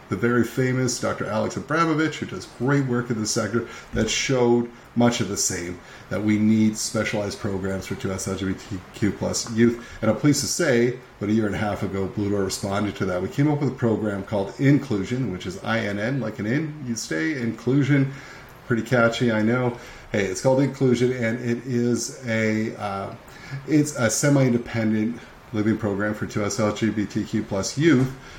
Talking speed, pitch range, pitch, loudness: 205 wpm, 105-125 Hz, 115 Hz, -23 LUFS